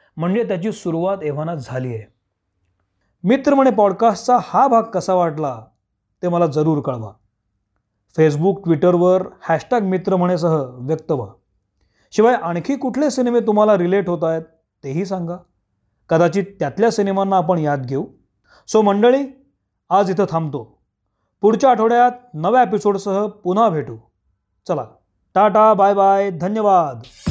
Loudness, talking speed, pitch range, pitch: -17 LUFS, 125 wpm, 130-205 Hz, 175 Hz